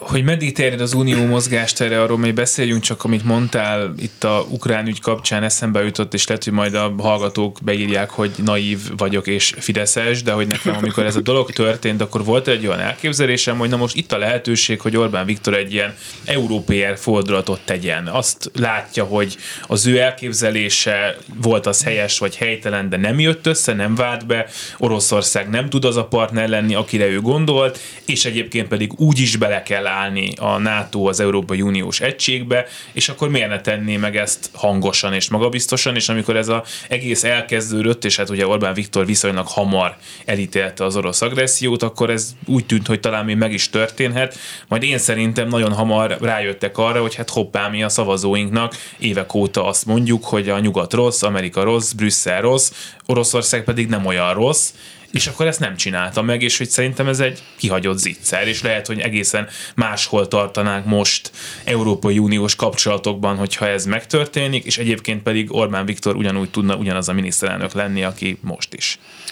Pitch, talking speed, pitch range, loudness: 110 Hz, 180 wpm, 100-120 Hz, -18 LUFS